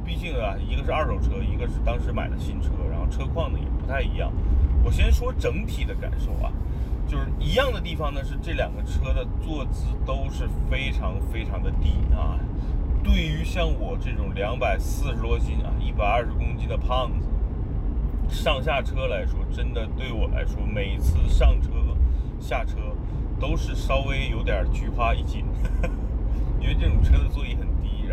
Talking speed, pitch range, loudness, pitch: 260 characters per minute, 70-75 Hz, -26 LUFS, 75 Hz